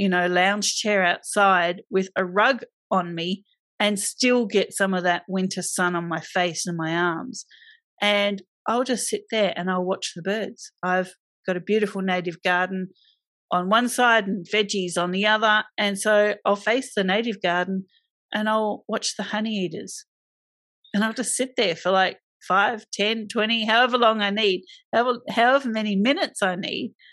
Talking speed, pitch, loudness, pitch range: 180 wpm, 205 Hz, -23 LUFS, 185-225 Hz